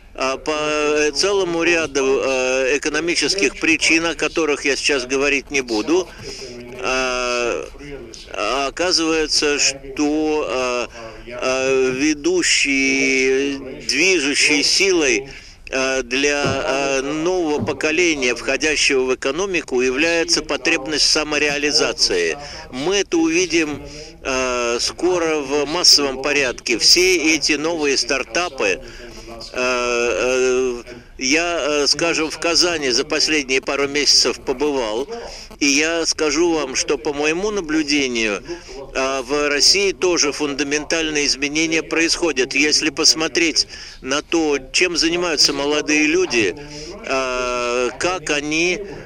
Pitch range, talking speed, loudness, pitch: 135-170 Hz, 85 wpm, -17 LUFS, 150 Hz